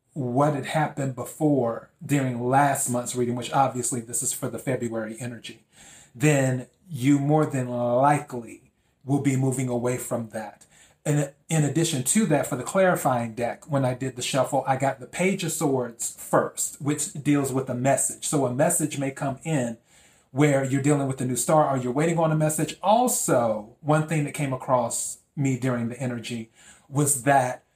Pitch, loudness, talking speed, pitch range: 135 Hz, -24 LUFS, 180 wpm, 125-150 Hz